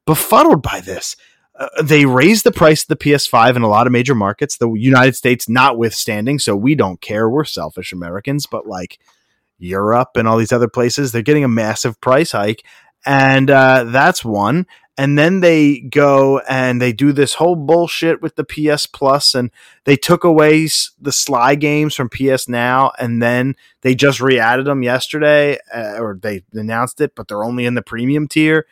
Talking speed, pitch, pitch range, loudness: 190 wpm, 135 Hz, 120-150 Hz, -14 LUFS